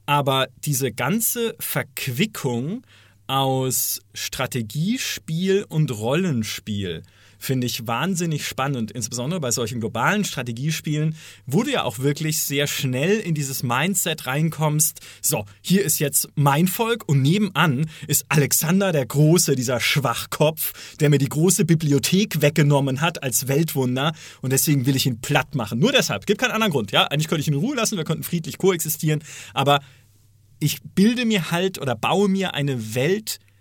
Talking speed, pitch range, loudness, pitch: 155 wpm, 130-170 Hz, -21 LUFS, 145 Hz